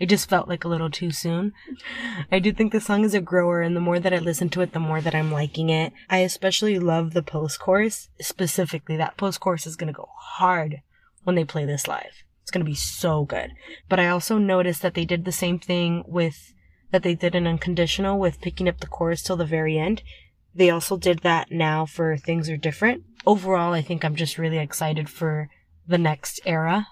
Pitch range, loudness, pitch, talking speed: 160-185 Hz, -23 LUFS, 175 Hz, 225 wpm